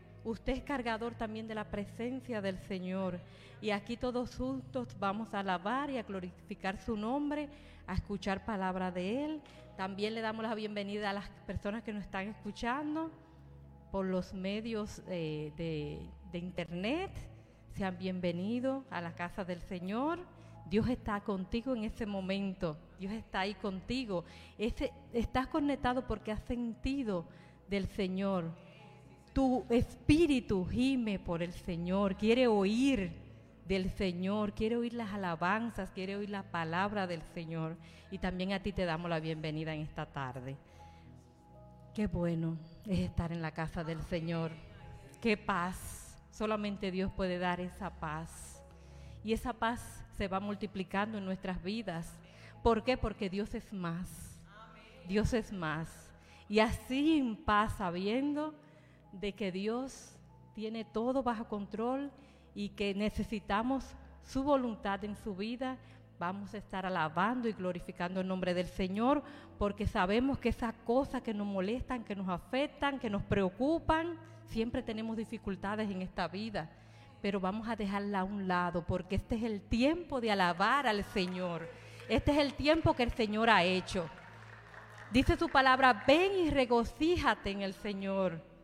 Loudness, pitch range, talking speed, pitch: -35 LUFS, 180-230 Hz, 150 wpm, 200 Hz